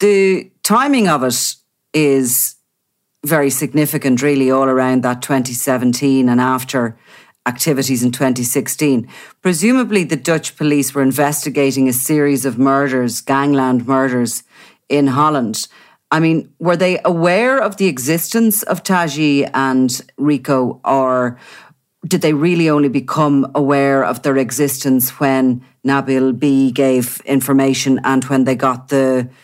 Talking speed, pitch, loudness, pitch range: 130 wpm, 135 Hz, -15 LUFS, 130-150 Hz